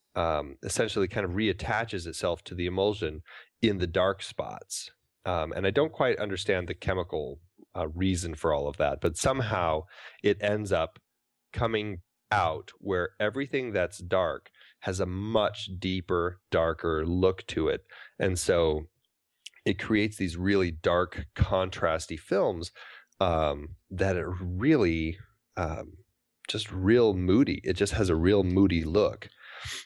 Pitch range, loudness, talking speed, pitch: 85-105 Hz, -29 LUFS, 140 wpm, 95 Hz